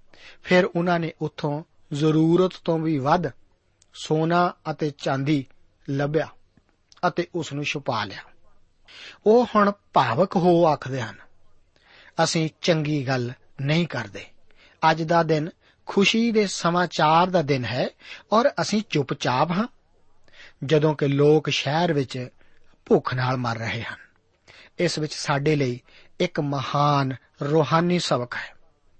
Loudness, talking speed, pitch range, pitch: -23 LUFS, 125 wpm, 135-170 Hz, 155 Hz